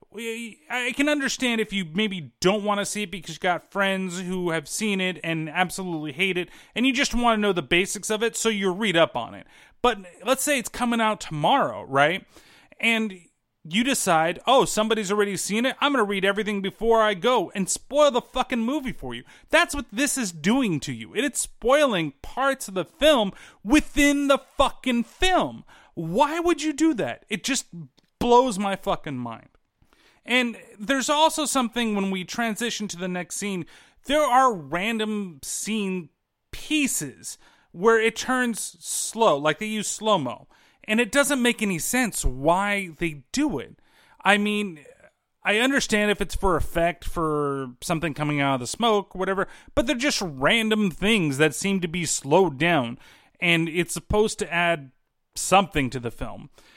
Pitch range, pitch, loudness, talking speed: 170-245 Hz, 205 Hz, -23 LUFS, 180 wpm